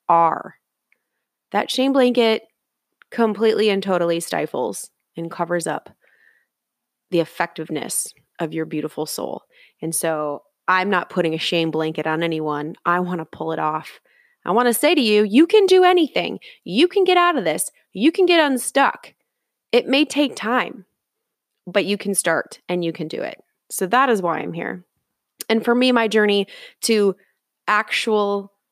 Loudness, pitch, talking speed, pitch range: -20 LUFS, 200 Hz, 165 wpm, 165-245 Hz